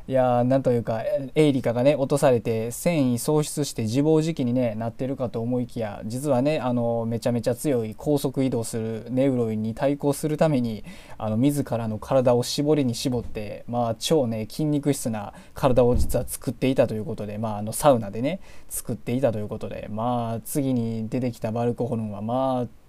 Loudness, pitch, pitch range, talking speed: -24 LUFS, 120 Hz, 115-140 Hz, 390 characters per minute